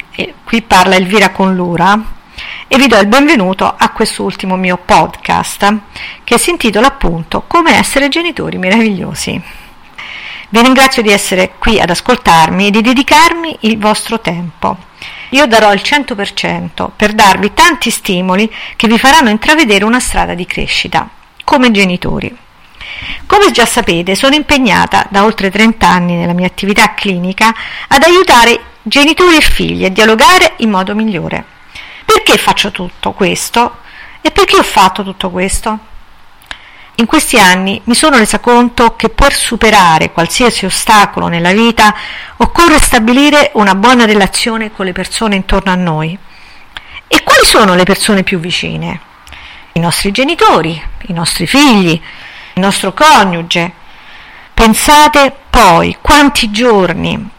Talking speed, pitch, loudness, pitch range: 140 wpm, 215 Hz, -8 LUFS, 185-255 Hz